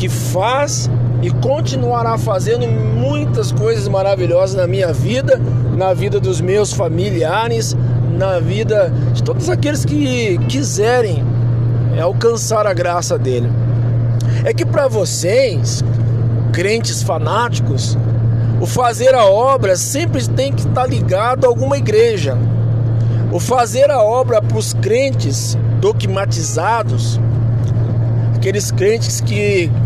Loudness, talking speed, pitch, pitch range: -15 LUFS, 115 wpm, 120 Hz, 115-125 Hz